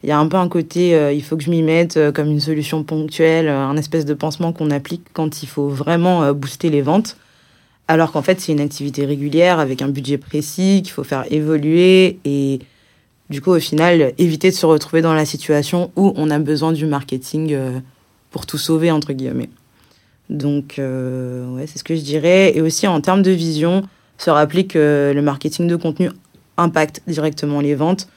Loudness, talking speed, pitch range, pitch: -17 LUFS, 210 wpm, 145-170 Hz, 155 Hz